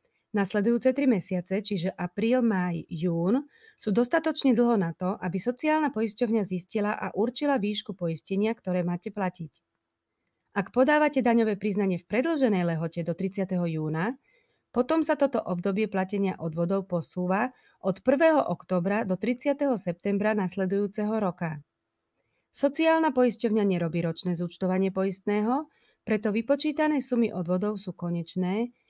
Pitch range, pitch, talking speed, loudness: 180-245 Hz, 205 Hz, 125 wpm, -27 LUFS